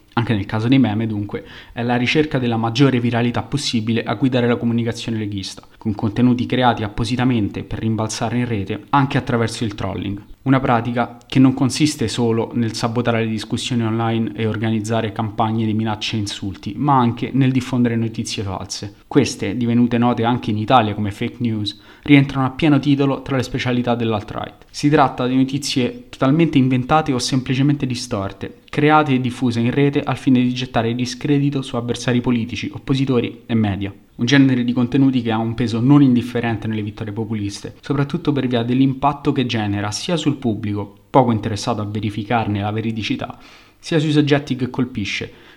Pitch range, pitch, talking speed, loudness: 110-130 Hz, 120 Hz, 170 wpm, -19 LUFS